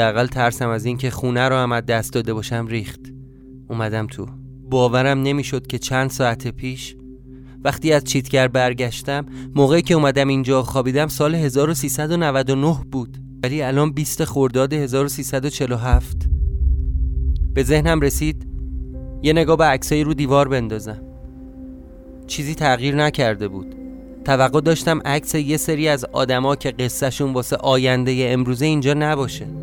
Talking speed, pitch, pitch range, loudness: 130 wpm, 130 Hz, 120-145 Hz, -19 LUFS